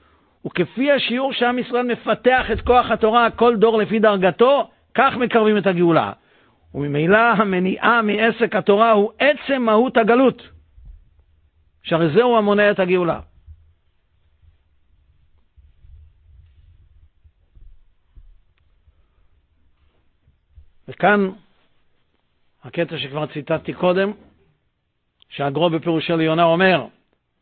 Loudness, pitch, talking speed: -18 LUFS, 160 Hz, 85 wpm